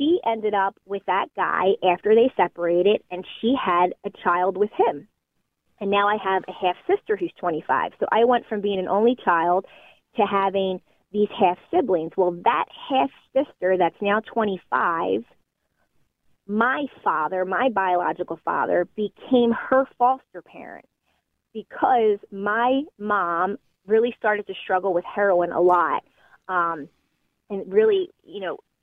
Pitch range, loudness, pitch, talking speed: 185-230 Hz, -22 LUFS, 200 Hz, 145 wpm